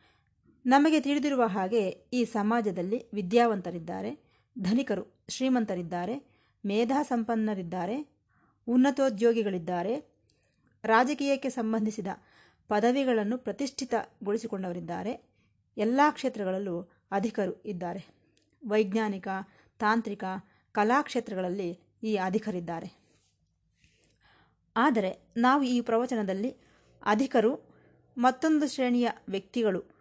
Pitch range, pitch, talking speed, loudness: 195-250 Hz, 225 Hz, 60 wpm, -29 LUFS